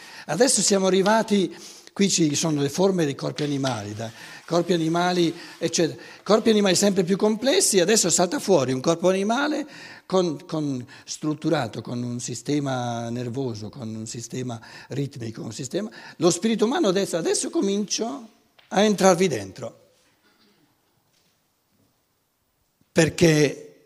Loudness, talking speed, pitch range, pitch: -23 LUFS, 125 wpm, 140-200 Hz, 175 Hz